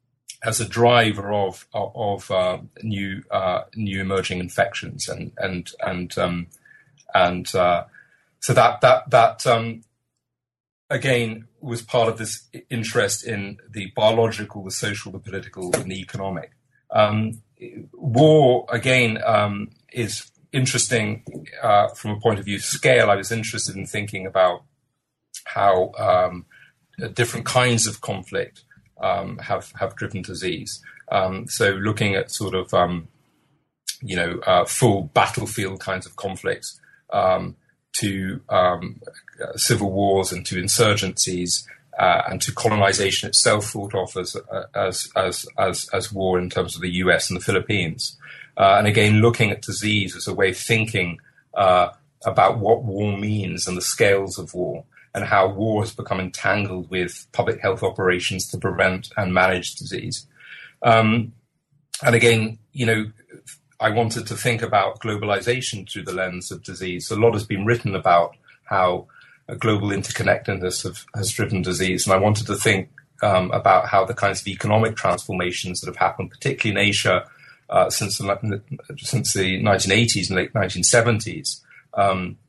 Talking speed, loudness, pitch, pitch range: 155 wpm, -21 LUFS, 105 Hz, 95-115 Hz